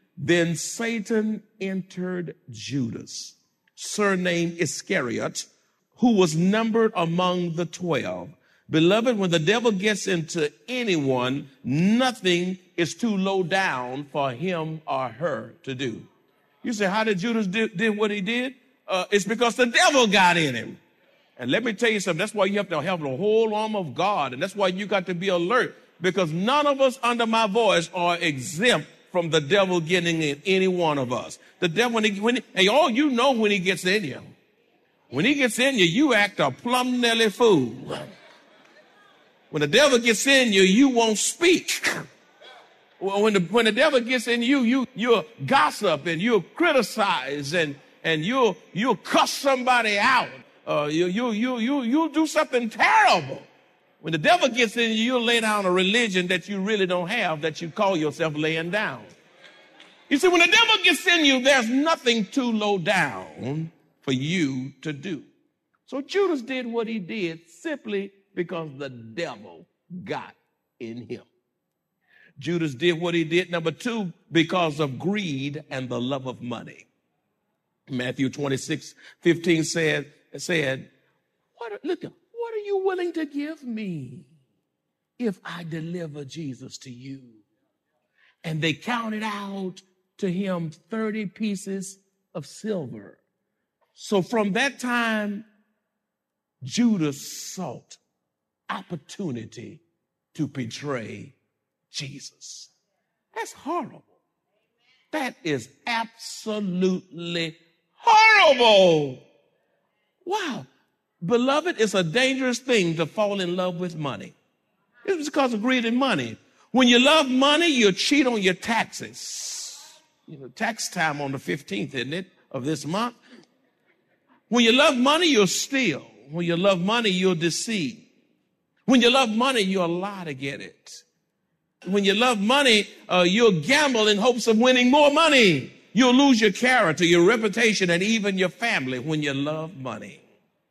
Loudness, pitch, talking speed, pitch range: -22 LUFS, 200 Hz, 150 wpm, 165-240 Hz